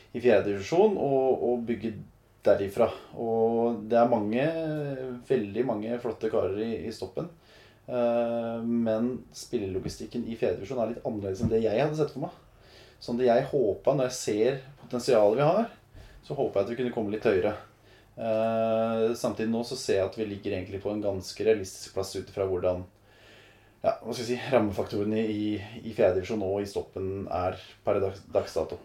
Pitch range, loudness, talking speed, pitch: 100-120 Hz, -28 LUFS, 175 wpm, 110 Hz